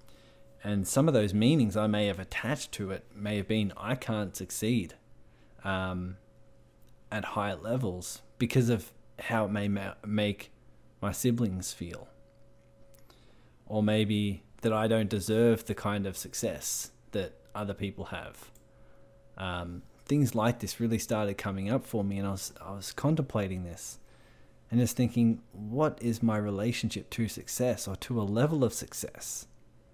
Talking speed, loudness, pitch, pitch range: 155 wpm, -31 LUFS, 105 Hz, 95-115 Hz